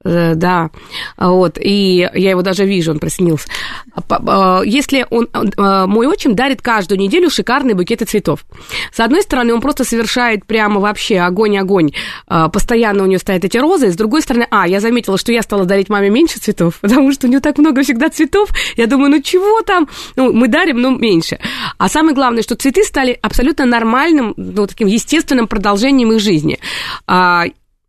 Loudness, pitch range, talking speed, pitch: -13 LUFS, 195-270 Hz, 170 wpm, 230 Hz